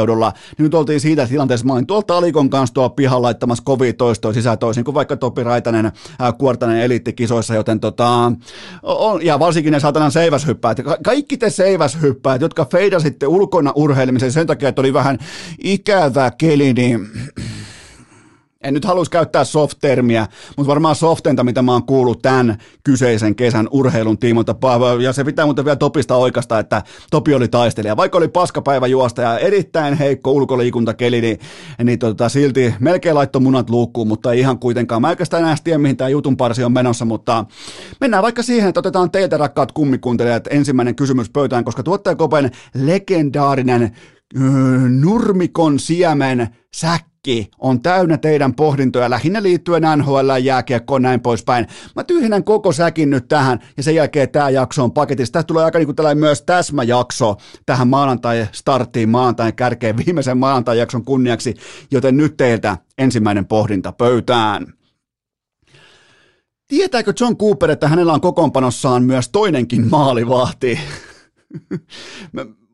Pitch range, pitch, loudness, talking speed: 120-155 Hz, 135 Hz, -15 LUFS, 150 wpm